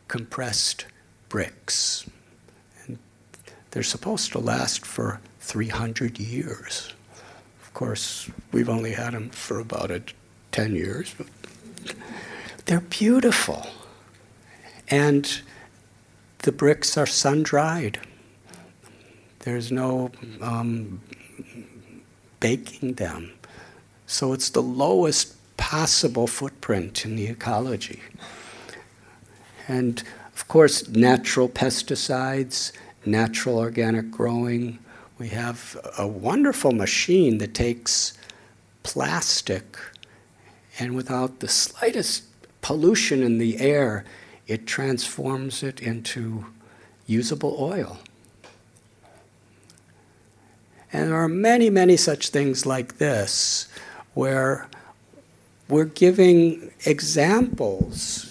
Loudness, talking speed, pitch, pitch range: -23 LUFS, 90 wpm, 120 Hz, 110-135 Hz